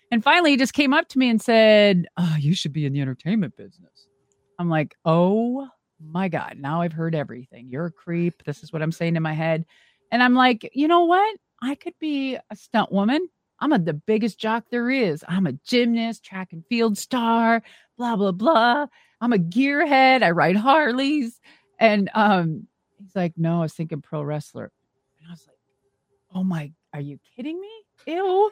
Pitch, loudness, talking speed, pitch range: 200 Hz, -21 LUFS, 200 wpm, 160-250 Hz